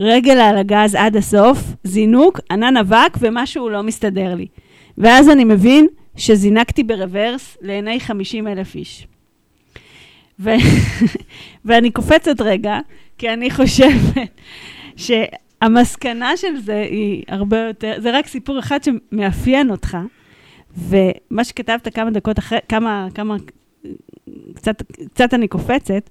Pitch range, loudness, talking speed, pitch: 210-250 Hz, -15 LUFS, 115 wpm, 225 Hz